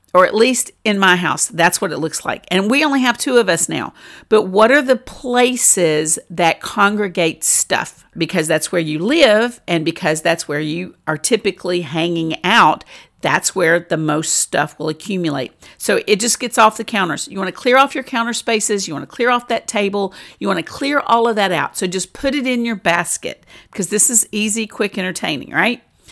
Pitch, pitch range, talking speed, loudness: 200 Hz, 170-235 Hz, 210 wpm, -16 LUFS